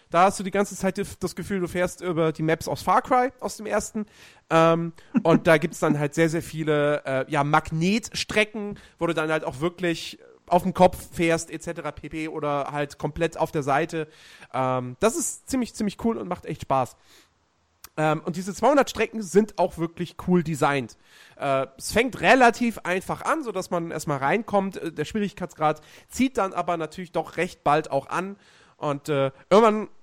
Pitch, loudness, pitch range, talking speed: 170 Hz, -24 LUFS, 155-200 Hz, 190 wpm